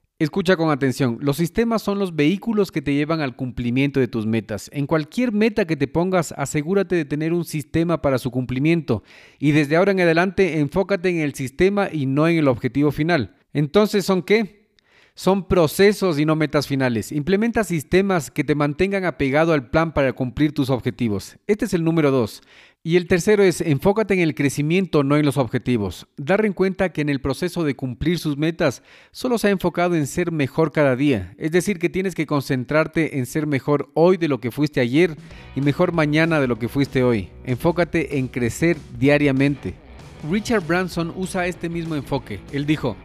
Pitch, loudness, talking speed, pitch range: 155 Hz, -20 LUFS, 190 wpm, 140-180 Hz